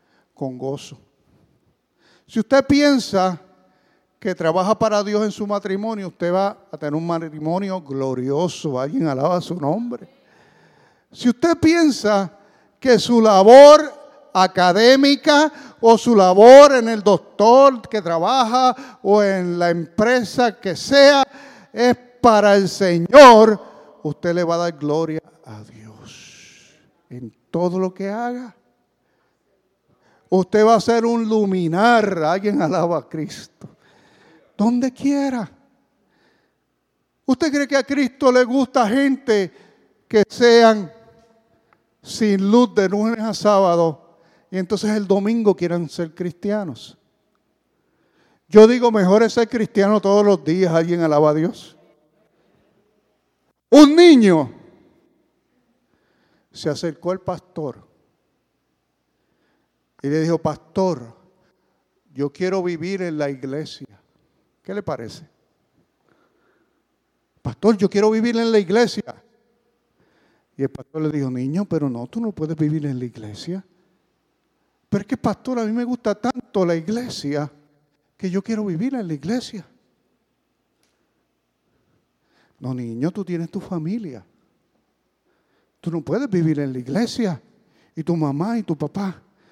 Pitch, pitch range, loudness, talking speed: 195 Hz, 165-230 Hz, -17 LUFS, 125 wpm